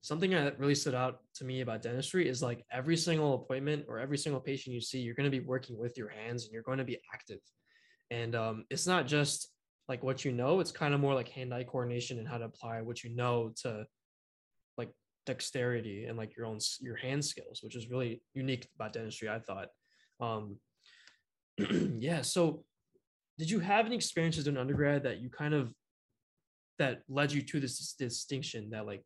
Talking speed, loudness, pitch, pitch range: 200 wpm, -35 LUFS, 130 Hz, 115-145 Hz